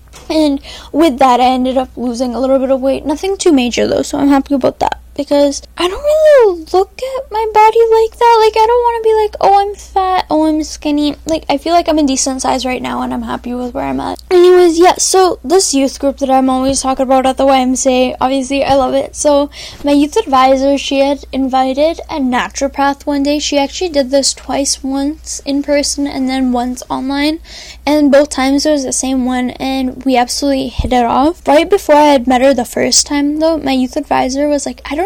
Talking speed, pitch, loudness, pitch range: 230 wpm, 280 Hz, -12 LUFS, 265-315 Hz